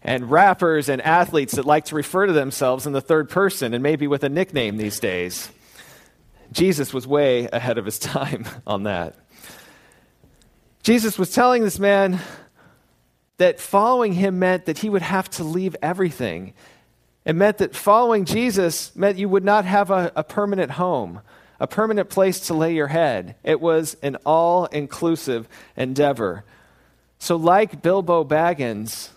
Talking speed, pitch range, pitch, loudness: 160 wpm, 135-190 Hz, 165 Hz, -20 LUFS